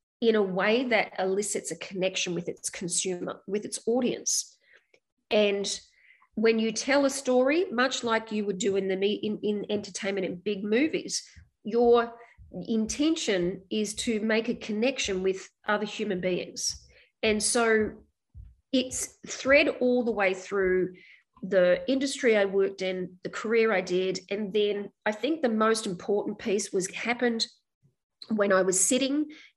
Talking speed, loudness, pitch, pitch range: 150 wpm, -27 LUFS, 215 Hz, 195-240 Hz